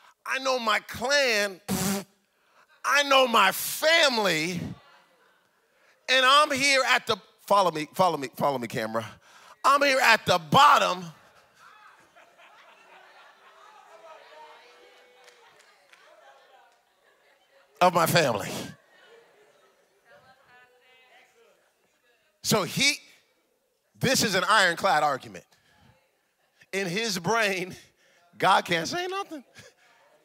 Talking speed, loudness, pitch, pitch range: 85 wpm, -23 LUFS, 220 Hz, 180-280 Hz